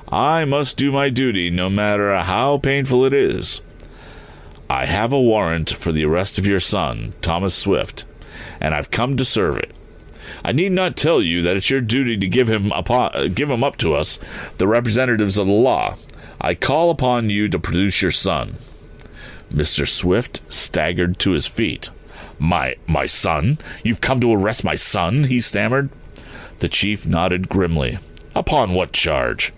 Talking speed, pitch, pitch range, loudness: 170 wpm, 105 Hz, 90-130 Hz, -18 LUFS